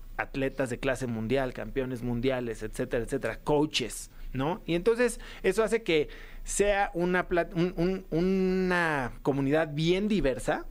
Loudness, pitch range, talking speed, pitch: -29 LUFS, 130-180 Hz, 130 wpm, 150 Hz